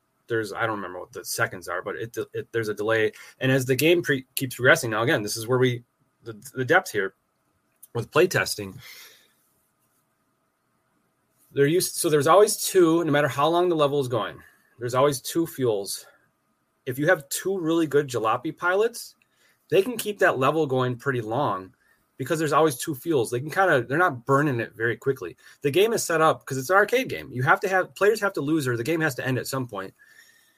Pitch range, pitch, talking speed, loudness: 130-180 Hz, 145 Hz, 215 wpm, -24 LUFS